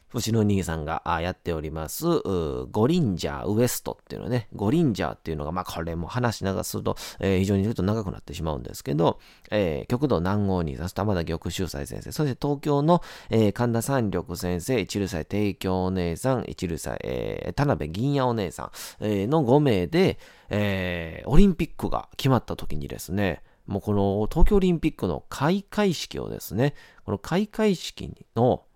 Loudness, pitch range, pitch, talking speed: -26 LUFS, 85-125 Hz, 100 Hz, 370 characters per minute